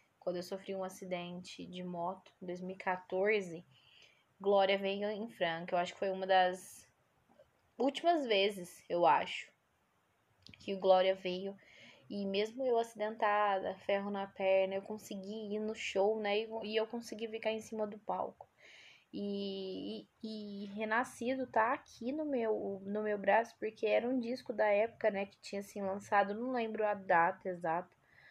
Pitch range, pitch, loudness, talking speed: 185-220 Hz, 200 Hz, -36 LUFS, 160 wpm